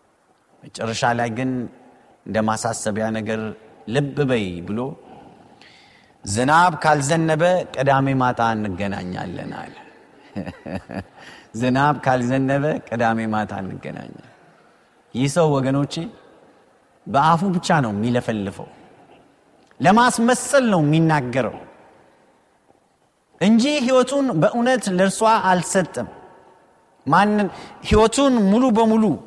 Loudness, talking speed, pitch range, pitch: -19 LUFS, 80 wpm, 115-190 Hz, 145 Hz